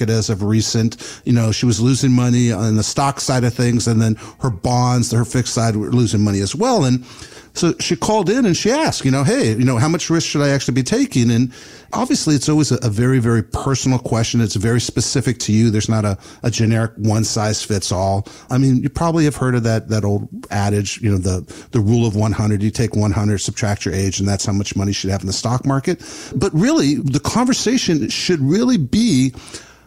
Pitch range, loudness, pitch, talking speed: 110-135 Hz, -17 LUFS, 120 Hz, 235 wpm